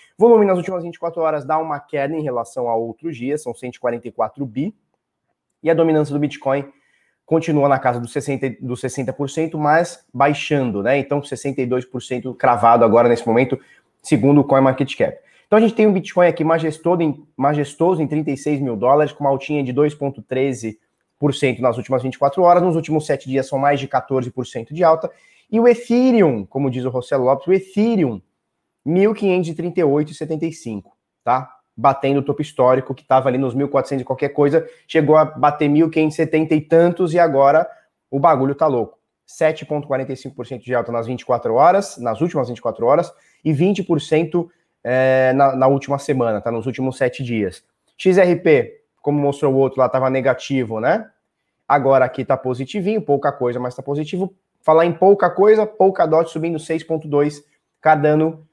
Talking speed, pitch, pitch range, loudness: 165 wpm, 145 Hz, 130-165 Hz, -18 LUFS